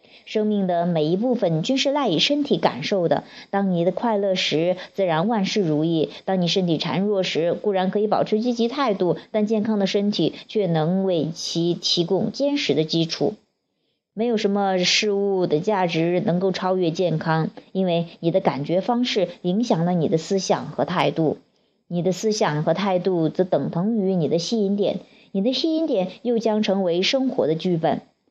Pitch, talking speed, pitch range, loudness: 190 Hz, 265 characters per minute, 170-215 Hz, -22 LUFS